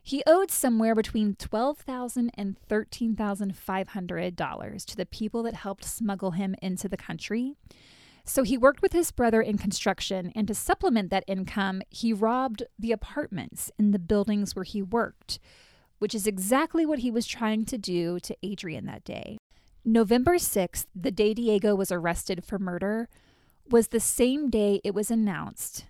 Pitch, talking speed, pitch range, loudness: 215 Hz, 170 wpm, 195-235 Hz, -27 LUFS